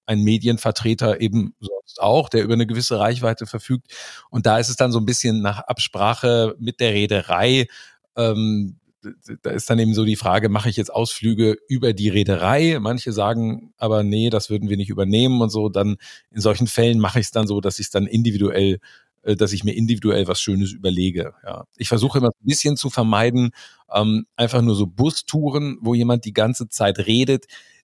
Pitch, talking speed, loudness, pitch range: 115 Hz, 195 wpm, -20 LUFS, 105-120 Hz